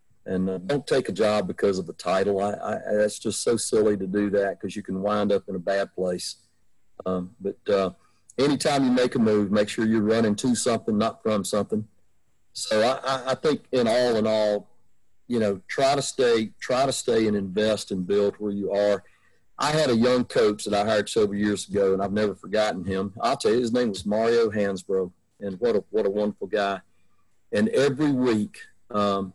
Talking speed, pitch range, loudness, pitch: 210 wpm, 95-110 Hz, -24 LUFS, 105 Hz